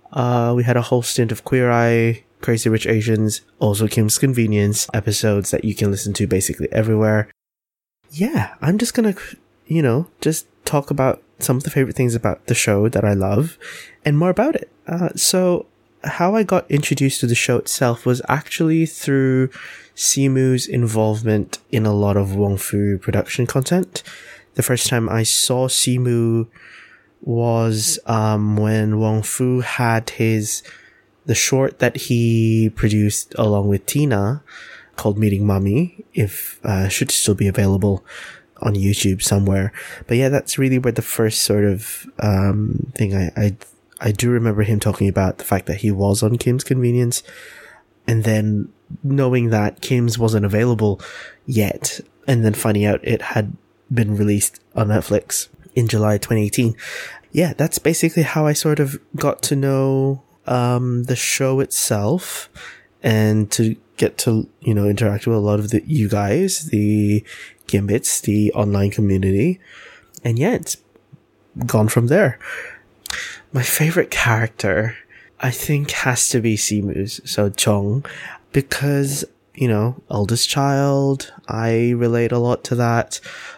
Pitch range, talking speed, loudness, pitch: 105-135 Hz, 150 wpm, -18 LUFS, 115 Hz